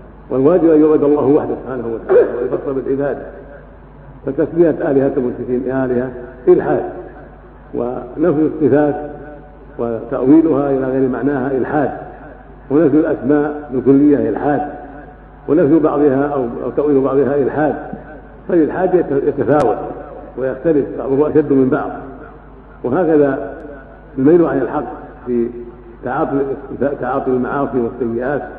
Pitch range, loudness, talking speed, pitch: 130-150 Hz, -15 LUFS, 95 wpm, 140 Hz